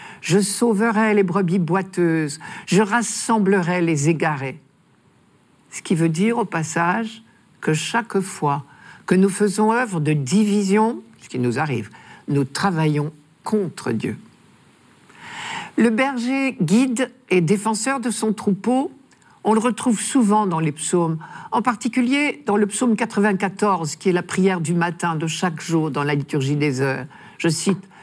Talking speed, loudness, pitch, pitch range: 150 wpm, -20 LUFS, 195 Hz, 160-225 Hz